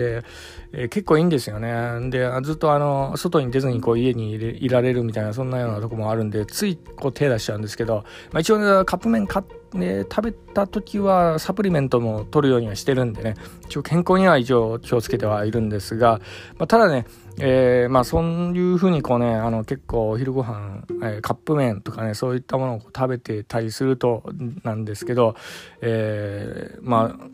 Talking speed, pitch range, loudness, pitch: 395 characters per minute, 110-150 Hz, -22 LUFS, 125 Hz